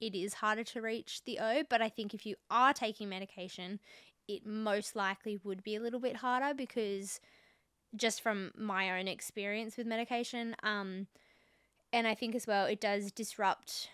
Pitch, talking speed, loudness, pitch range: 215 Hz, 175 wpm, -36 LUFS, 200-230 Hz